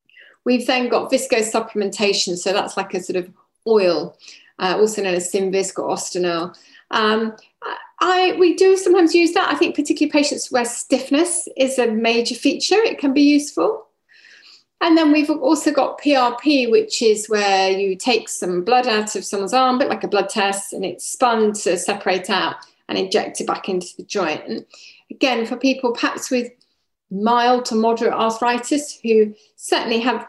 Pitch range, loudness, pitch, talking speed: 205-290 Hz, -18 LUFS, 240 Hz, 170 wpm